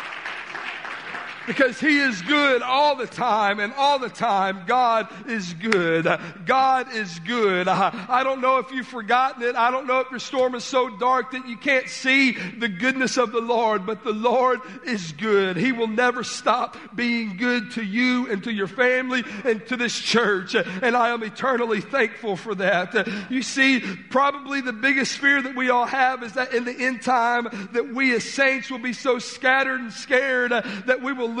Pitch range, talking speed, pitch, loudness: 220-255 Hz, 195 wpm, 245 Hz, -22 LUFS